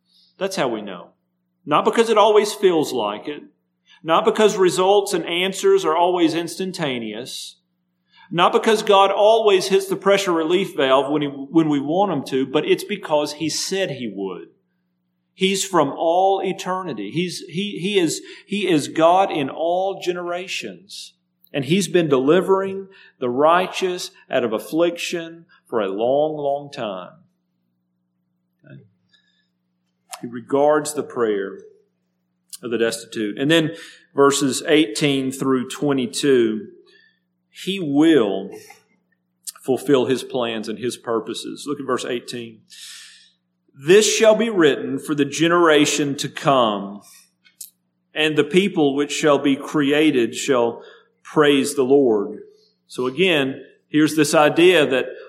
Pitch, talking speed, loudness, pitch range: 155 Hz, 130 wpm, -19 LUFS, 125-190 Hz